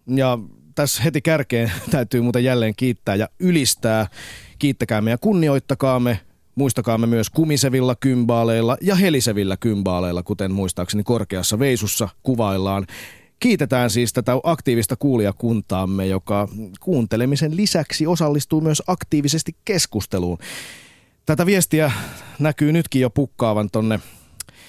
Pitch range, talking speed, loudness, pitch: 105-145 Hz, 110 wpm, -20 LUFS, 120 Hz